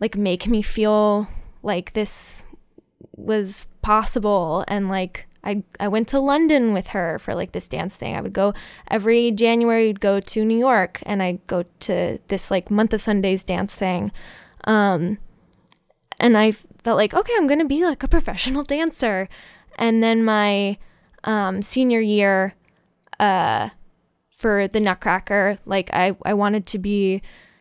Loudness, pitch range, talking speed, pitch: -20 LUFS, 195-225 Hz, 155 wpm, 210 Hz